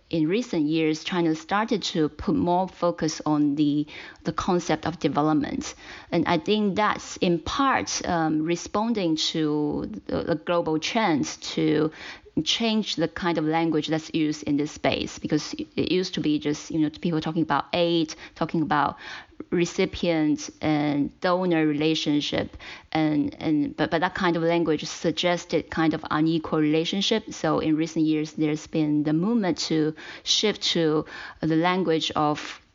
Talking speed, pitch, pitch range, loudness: 155 wpm, 160 Hz, 155-175 Hz, -25 LUFS